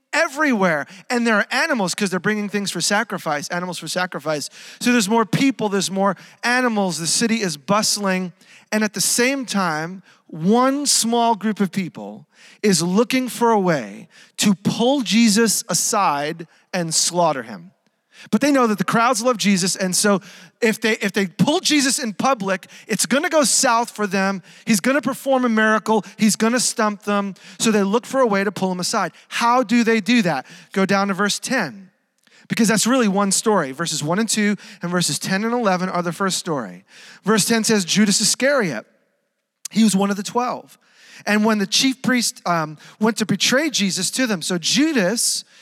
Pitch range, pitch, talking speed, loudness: 190-235 Hz, 210 Hz, 190 wpm, -19 LUFS